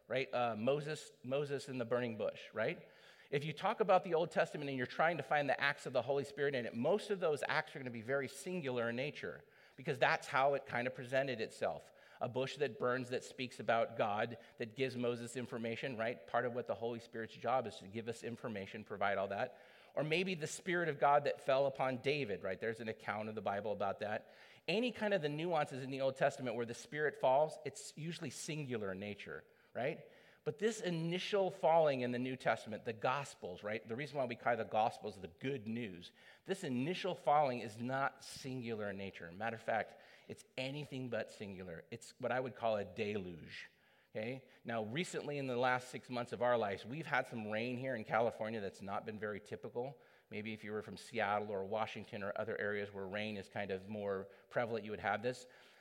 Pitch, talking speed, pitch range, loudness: 125 Hz, 220 wpm, 115-140 Hz, -39 LUFS